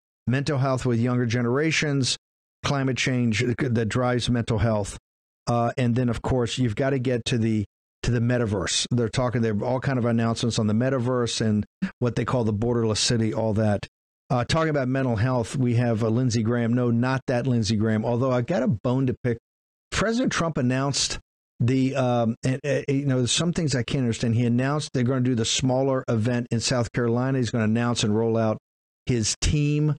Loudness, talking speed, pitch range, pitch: -24 LUFS, 205 wpm, 115-130 Hz, 120 Hz